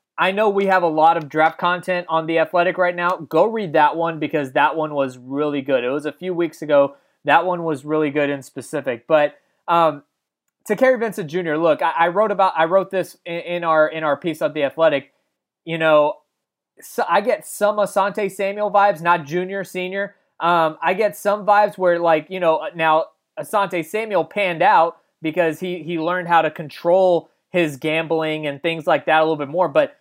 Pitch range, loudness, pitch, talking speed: 155-190 Hz, -19 LUFS, 170 Hz, 210 wpm